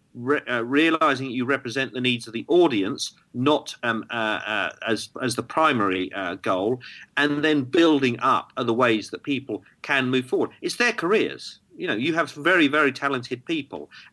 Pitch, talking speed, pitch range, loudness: 140 Hz, 175 wpm, 125-160 Hz, -23 LUFS